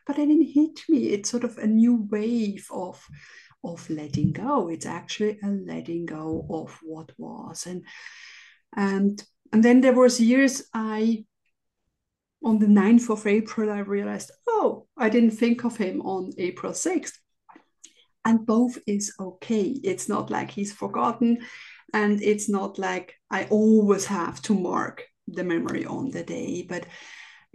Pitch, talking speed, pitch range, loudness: 215 Hz, 155 wpm, 200-240 Hz, -24 LUFS